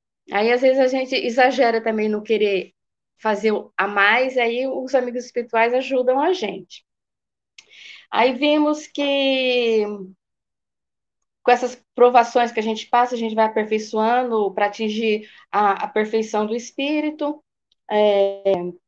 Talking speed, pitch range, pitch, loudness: 135 wpm, 215-255 Hz, 230 Hz, -20 LUFS